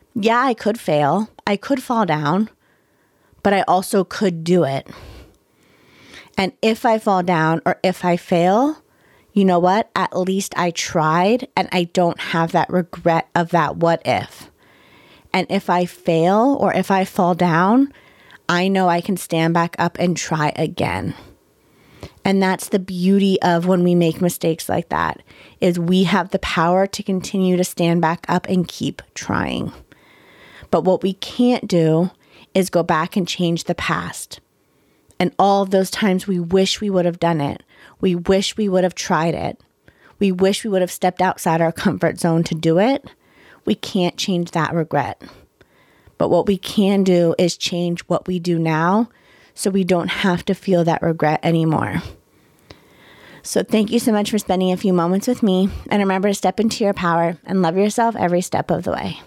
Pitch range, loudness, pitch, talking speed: 170-195 Hz, -19 LUFS, 185 Hz, 180 wpm